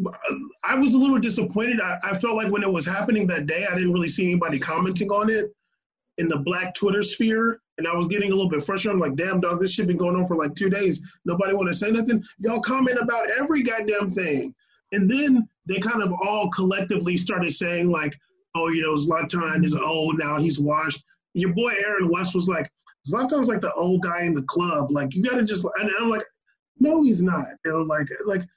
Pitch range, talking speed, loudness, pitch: 170-220 Hz, 225 wpm, -23 LUFS, 195 Hz